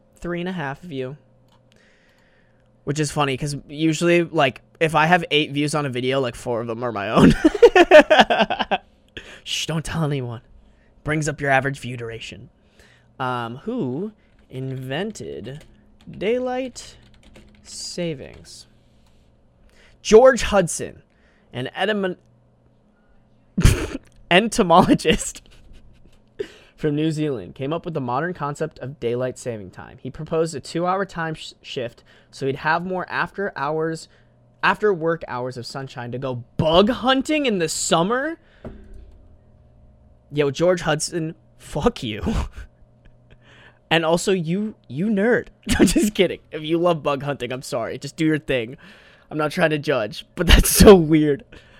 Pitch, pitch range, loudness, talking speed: 155 Hz, 130-175 Hz, -20 LUFS, 140 wpm